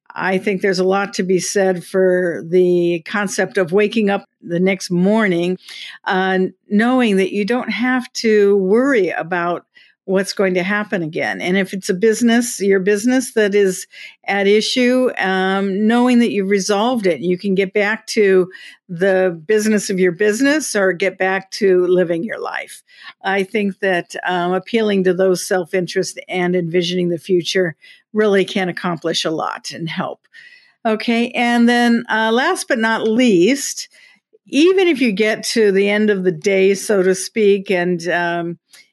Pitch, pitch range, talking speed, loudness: 195 Hz, 185-220 Hz, 165 wpm, -17 LUFS